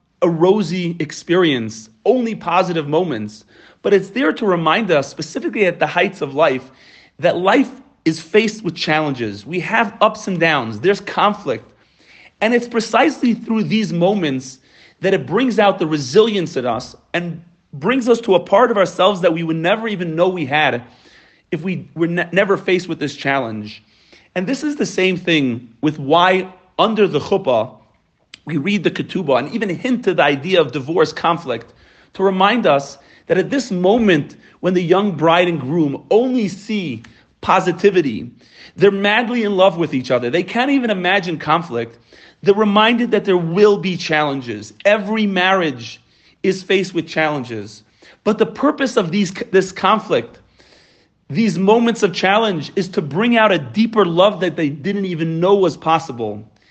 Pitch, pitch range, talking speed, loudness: 180 Hz, 155-205 Hz, 170 wpm, -17 LUFS